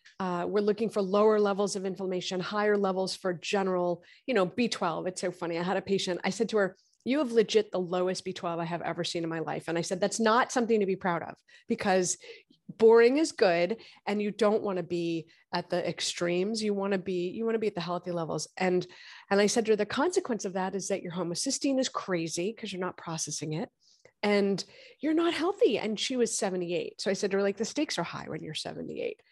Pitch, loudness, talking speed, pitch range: 195 Hz, -29 LUFS, 235 wpm, 180-225 Hz